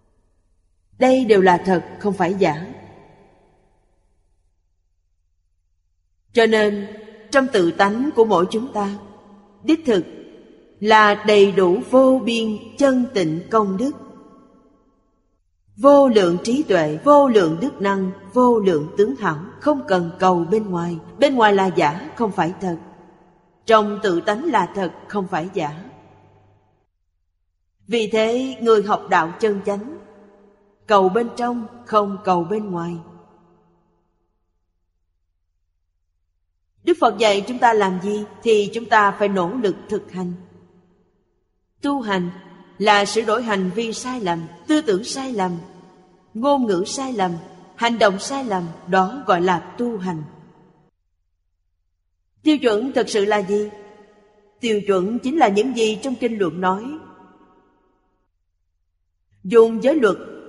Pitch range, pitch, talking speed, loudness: 165-220 Hz, 195 Hz, 130 wpm, -19 LUFS